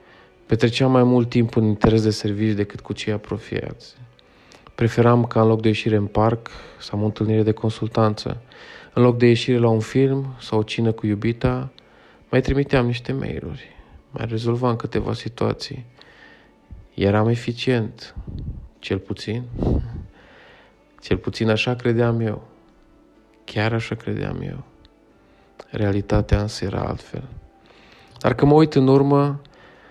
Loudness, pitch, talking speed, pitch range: -21 LUFS, 115 Hz, 140 wpm, 110-125 Hz